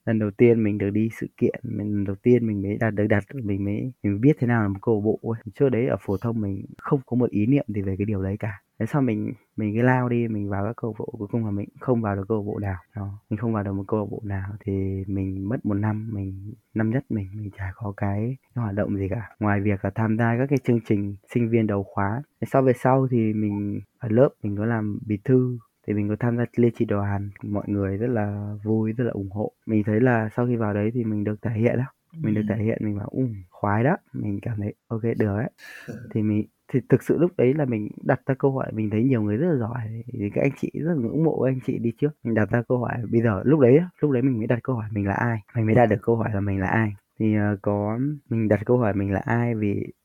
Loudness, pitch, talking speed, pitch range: -24 LUFS, 110 Hz, 285 wpm, 105-120 Hz